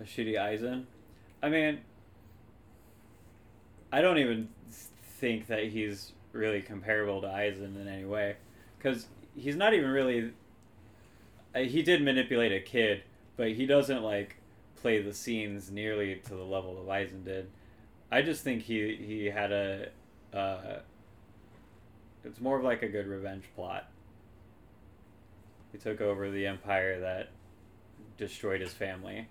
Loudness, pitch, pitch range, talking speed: -32 LUFS, 105 Hz, 100-110 Hz, 135 wpm